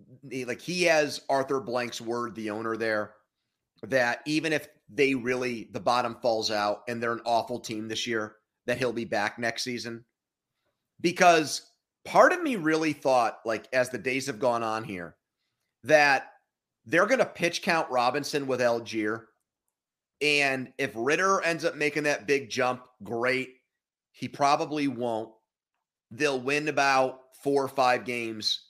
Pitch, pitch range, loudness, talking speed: 125 Hz, 115-145 Hz, -27 LUFS, 155 wpm